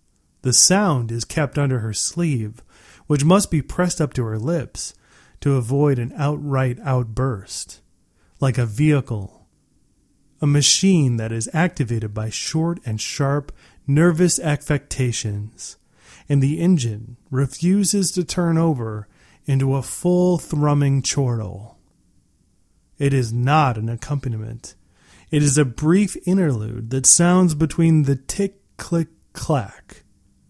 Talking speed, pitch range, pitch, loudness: 125 wpm, 115-160 Hz, 135 Hz, -20 LUFS